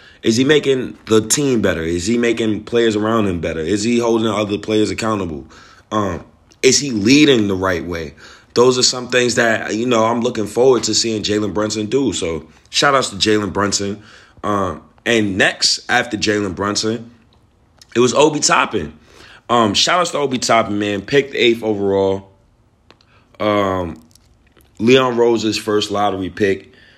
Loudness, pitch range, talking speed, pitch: -16 LUFS, 100-120 Hz, 160 wpm, 110 Hz